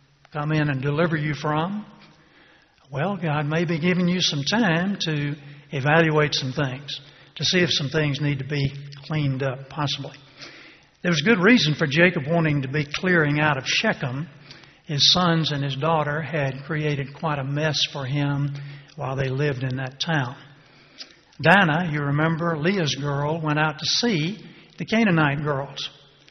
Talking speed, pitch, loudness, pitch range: 165 wpm, 150 Hz, -22 LUFS, 140-165 Hz